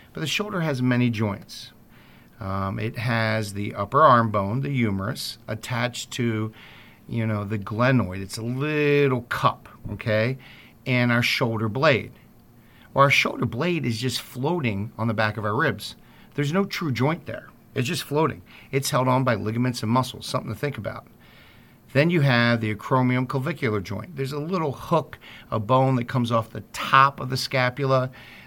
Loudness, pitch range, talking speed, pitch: -24 LUFS, 110-135 Hz, 175 wpm, 120 Hz